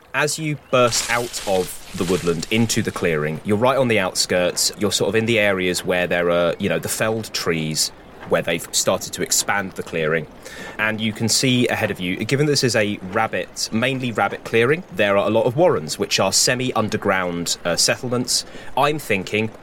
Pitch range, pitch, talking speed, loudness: 95-120 Hz, 110 Hz, 200 wpm, -20 LUFS